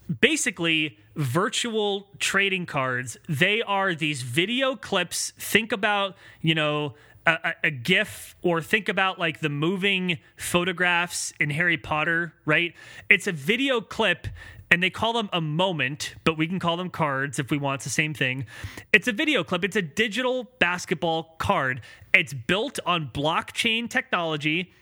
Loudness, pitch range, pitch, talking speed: -24 LUFS, 155-200 Hz, 175 Hz, 155 wpm